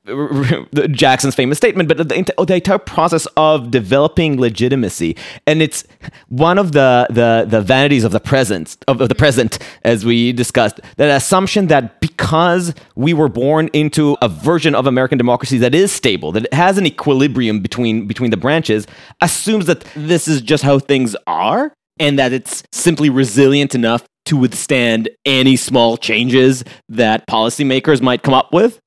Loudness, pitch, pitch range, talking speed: -14 LUFS, 135 Hz, 125-155 Hz, 160 wpm